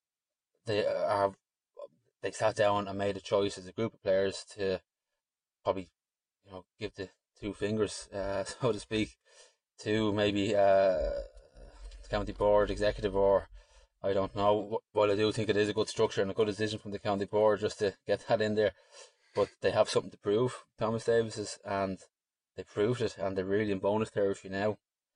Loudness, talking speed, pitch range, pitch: -31 LUFS, 190 wpm, 100-110 Hz, 105 Hz